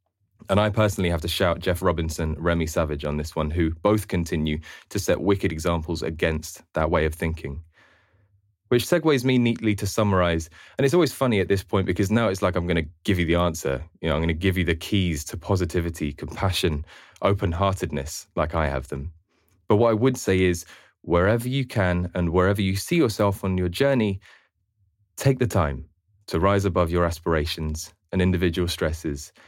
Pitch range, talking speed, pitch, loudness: 85-100 Hz, 195 wpm, 90 Hz, -24 LUFS